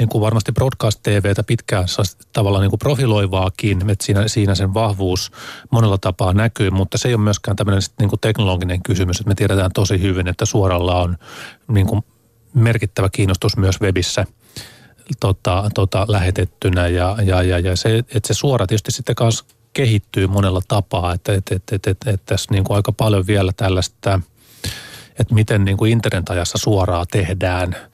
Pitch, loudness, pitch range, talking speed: 105 Hz, -18 LUFS, 95-115 Hz, 165 wpm